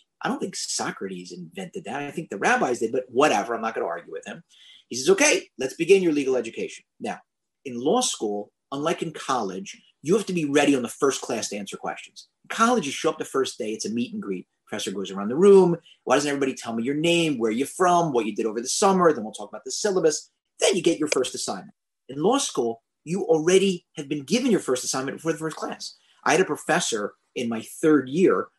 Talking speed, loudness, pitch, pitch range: 245 wpm, -24 LUFS, 160 Hz, 130-195 Hz